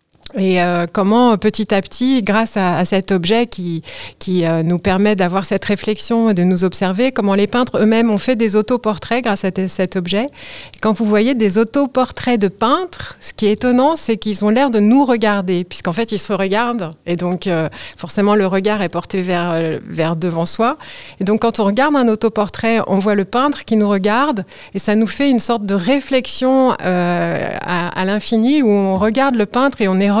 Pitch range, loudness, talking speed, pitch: 190-230 Hz, -16 LUFS, 215 wpm, 210 Hz